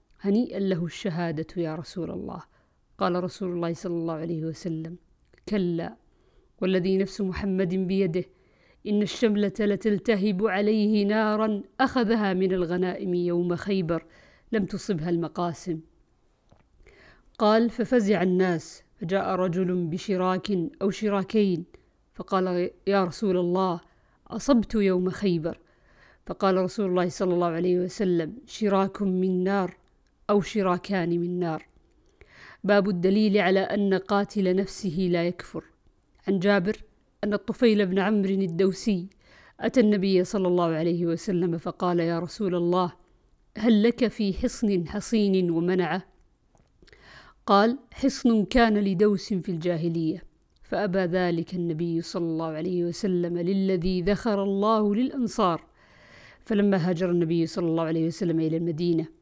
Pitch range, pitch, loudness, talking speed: 175-205 Hz, 185 Hz, -26 LUFS, 120 wpm